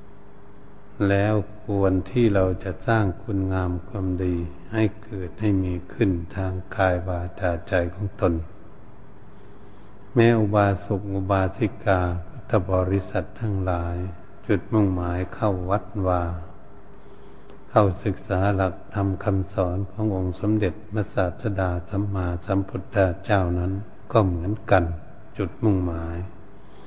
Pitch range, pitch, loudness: 90-105 Hz, 95 Hz, -24 LUFS